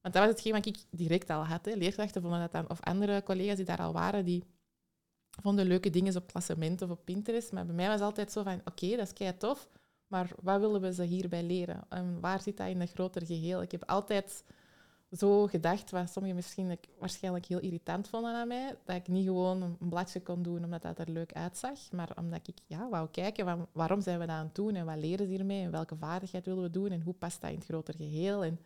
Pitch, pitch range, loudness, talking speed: 185 Hz, 175-200 Hz, -35 LUFS, 250 wpm